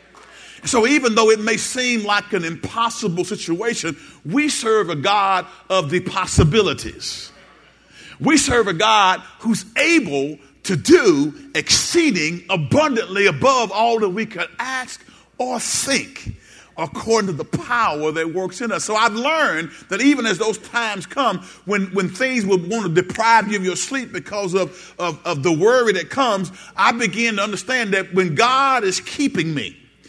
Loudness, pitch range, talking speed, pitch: -18 LUFS, 185-240 Hz, 160 wpm, 210 Hz